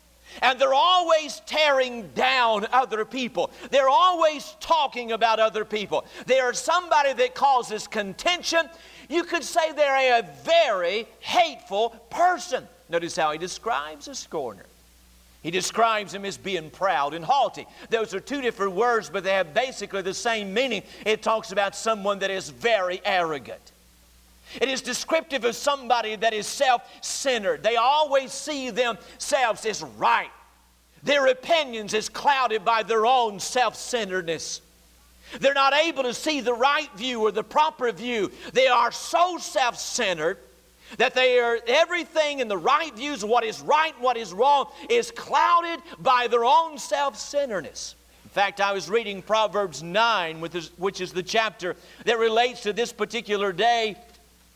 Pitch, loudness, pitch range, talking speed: 235 Hz, -24 LUFS, 200-275 Hz, 155 wpm